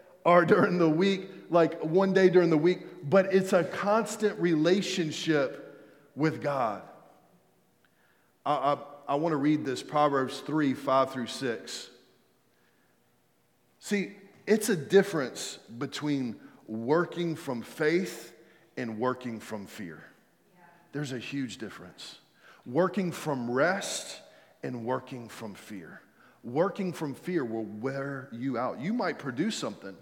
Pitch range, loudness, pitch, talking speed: 125-175 Hz, -29 LUFS, 155 Hz, 125 wpm